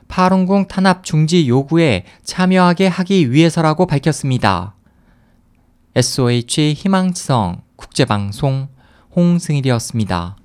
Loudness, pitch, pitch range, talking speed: -15 LUFS, 140 Hz, 110-180 Hz, 260 characters per minute